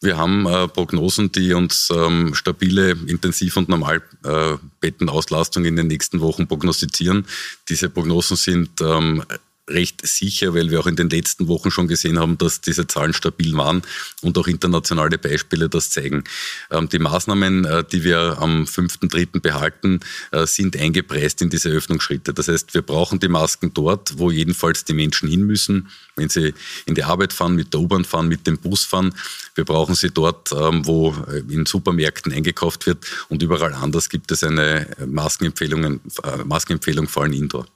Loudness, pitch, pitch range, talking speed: -19 LUFS, 85 Hz, 80-90 Hz, 165 wpm